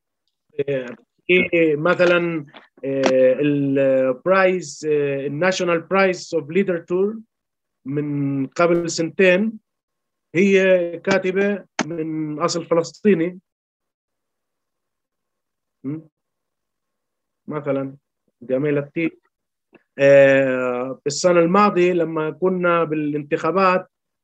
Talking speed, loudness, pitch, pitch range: 55 wpm, -19 LUFS, 165 Hz, 140-180 Hz